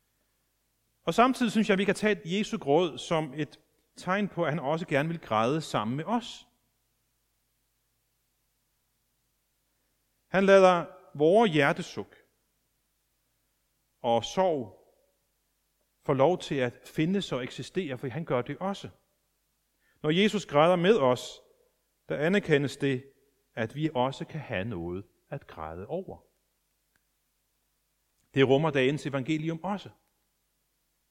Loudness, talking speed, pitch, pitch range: -28 LUFS, 120 wpm, 140 Hz, 125-180 Hz